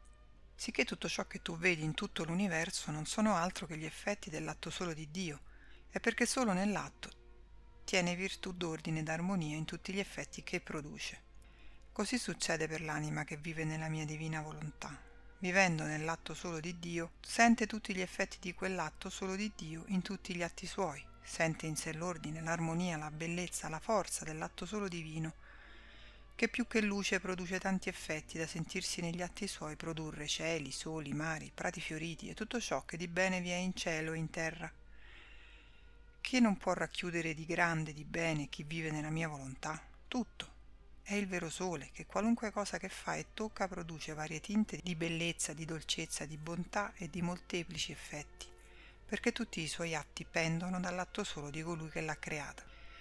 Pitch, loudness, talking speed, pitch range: 170 Hz, -38 LUFS, 180 wpm, 160-190 Hz